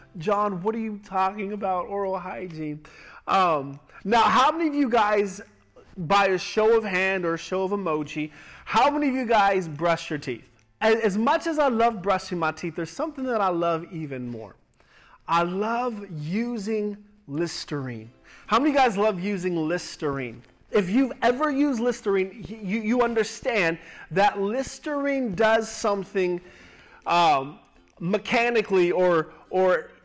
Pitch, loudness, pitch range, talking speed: 195 Hz, -24 LUFS, 170-225 Hz, 150 wpm